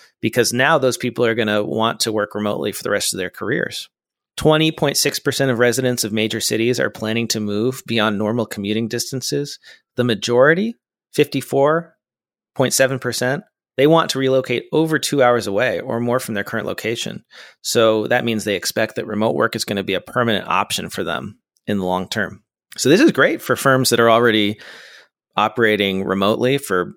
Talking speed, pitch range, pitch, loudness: 180 wpm, 110-135 Hz, 120 Hz, -18 LUFS